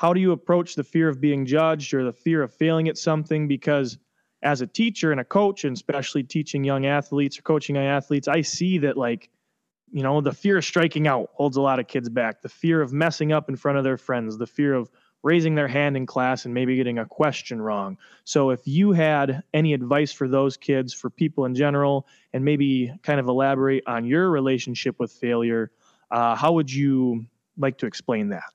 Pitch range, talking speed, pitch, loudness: 130-155 Hz, 220 wpm, 140 Hz, -23 LUFS